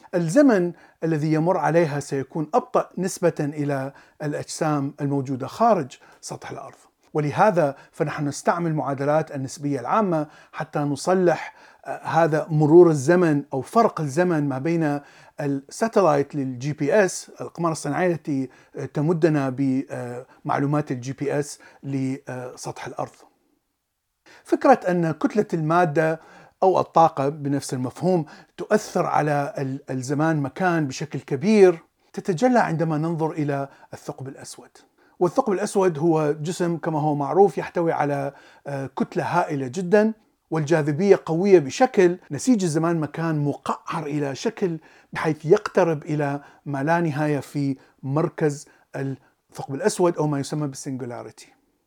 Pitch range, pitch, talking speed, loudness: 140-175 Hz, 155 Hz, 115 wpm, -22 LUFS